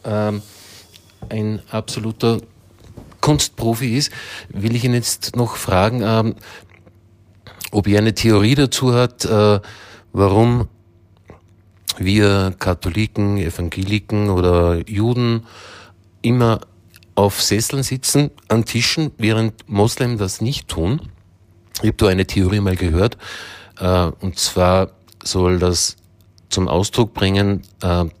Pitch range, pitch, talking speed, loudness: 95-115 Hz, 105 Hz, 110 wpm, -18 LUFS